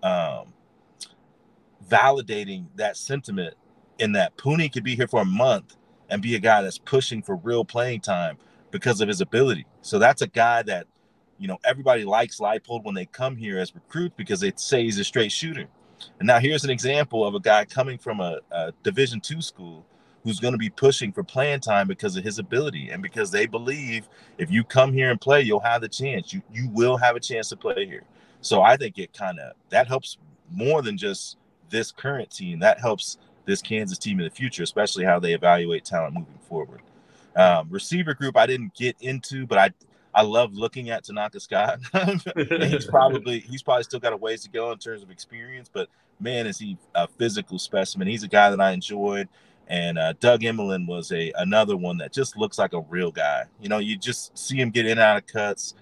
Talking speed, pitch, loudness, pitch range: 215 wpm, 130 Hz, -23 LUFS, 110-165 Hz